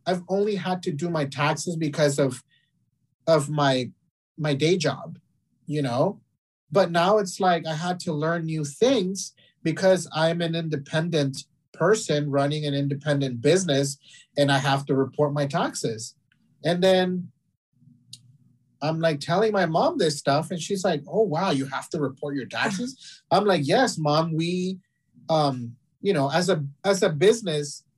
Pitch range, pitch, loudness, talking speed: 140-180 Hz, 155 Hz, -24 LUFS, 160 wpm